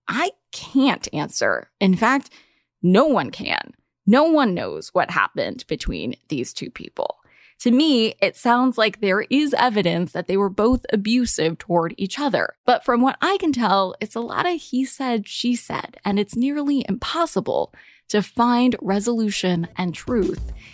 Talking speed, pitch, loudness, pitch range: 160 wpm, 235 Hz, -21 LUFS, 195-265 Hz